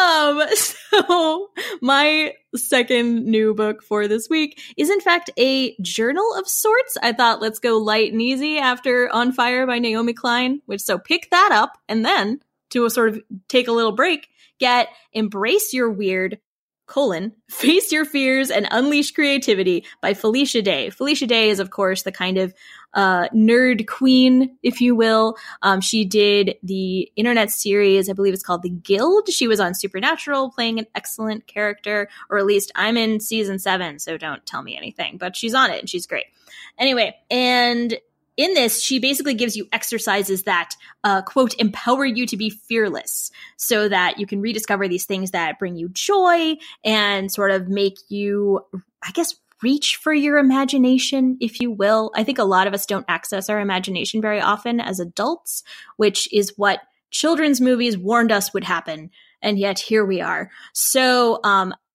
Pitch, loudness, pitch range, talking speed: 225 Hz, -19 LUFS, 200-265 Hz, 175 wpm